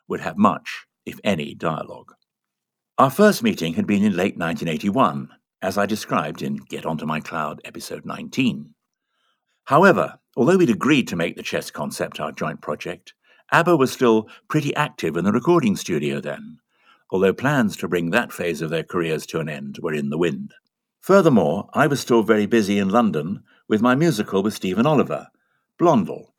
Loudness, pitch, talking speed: -21 LUFS, 130 Hz, 175 wpm